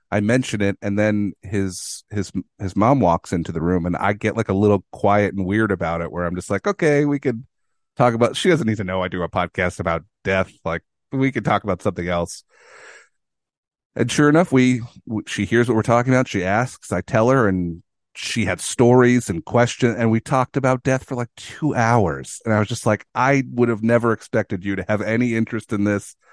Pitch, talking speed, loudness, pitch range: 105 Hz, 225 wpm, -20 LUFS, 95-120 Hz